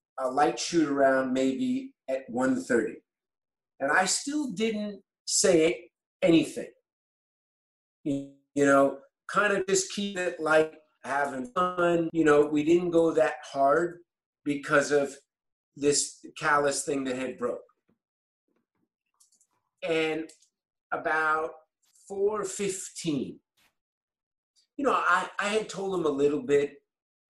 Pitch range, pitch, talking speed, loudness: 140-190 Hz, 155 Hz, 110 wpm, -27 LUFS